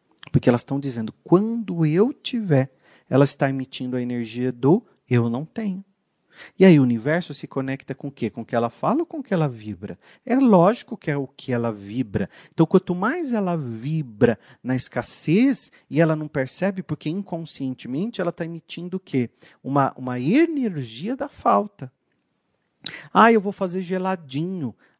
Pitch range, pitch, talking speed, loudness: 130-190 Hz, 155 Hz, 175 wpm, -22 LUFS